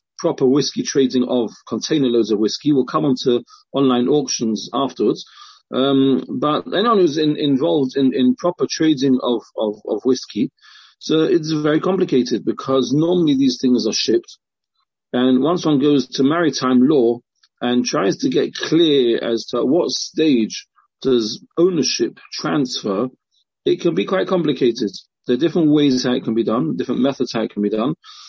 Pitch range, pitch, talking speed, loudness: 125-155 Hz, 135 Hz, 165 wpm, -18 LUFS